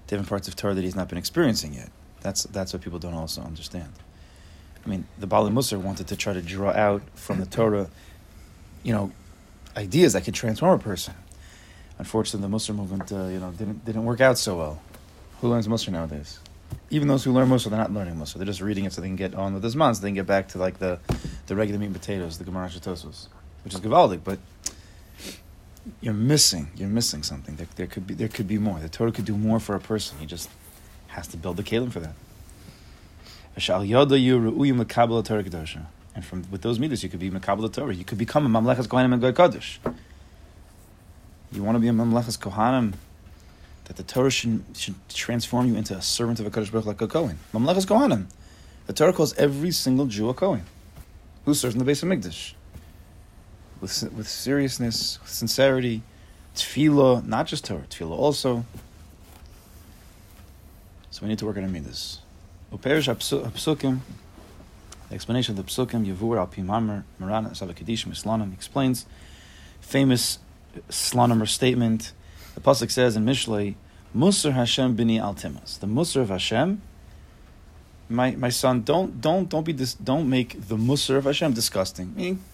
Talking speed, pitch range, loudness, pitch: 180 wpm, 90-115 Hz, -24 LUFS, 100 Hz